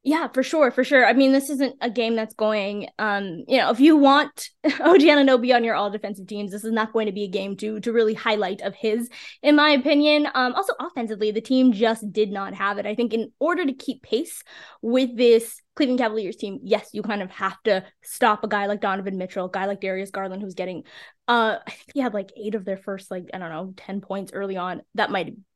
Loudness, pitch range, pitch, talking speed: -22 LUFS, 200-260 Hz, 220 Hz, 245 wpm